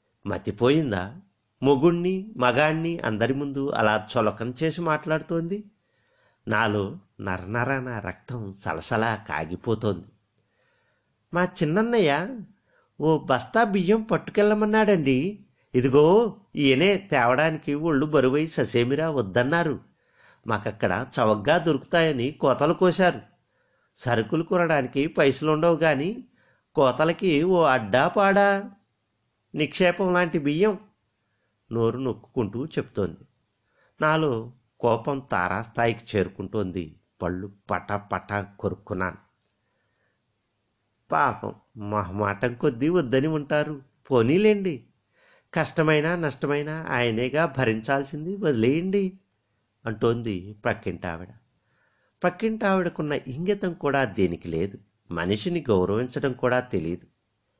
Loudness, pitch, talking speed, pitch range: -24 LUFS, 135 Hz, 80 wpm, 105-165 Hz